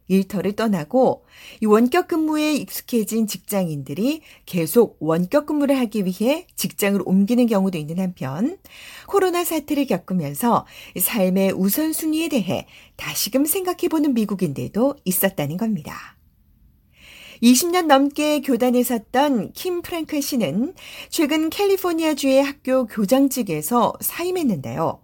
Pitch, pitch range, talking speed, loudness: 245 Hz, 195-300 Hz, 290 characters per minute, -21 LUFS